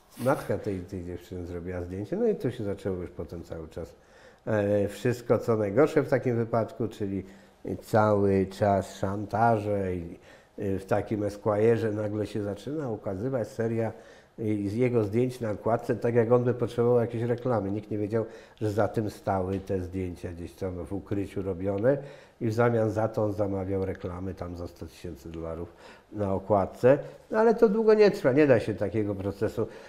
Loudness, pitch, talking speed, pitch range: -28 LUFS, 105 Hz, 175 wpm, 95-115 Hz